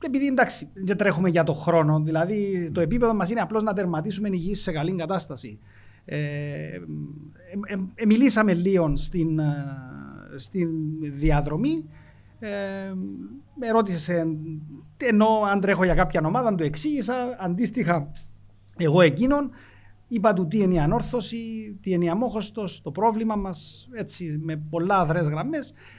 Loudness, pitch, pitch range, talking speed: -24 LUFS, 180 Hz, 155-215 Hz, 140 wpm